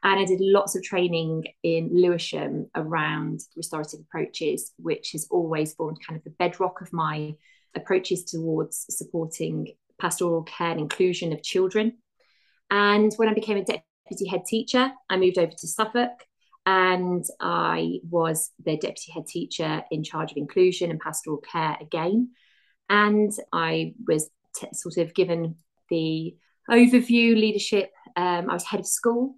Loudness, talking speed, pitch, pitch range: -25 LUFS, 150 wpm, 180 Hz, 160-205 Hz